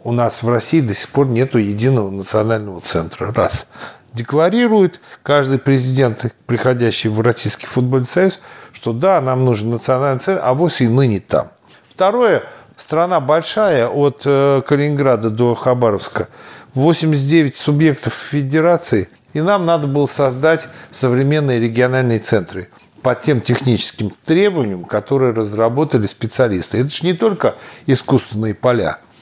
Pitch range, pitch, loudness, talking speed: 115-150 Hz, 130 Hz, -15 LUFS, 125 wpm